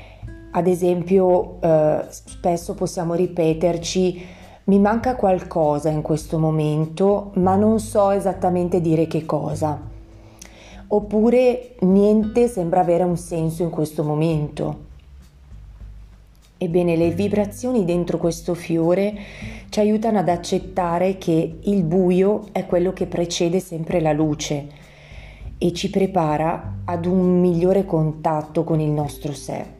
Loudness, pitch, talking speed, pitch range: -20 LUFS, 175 Hz, 120 wpm, 155-185 Hz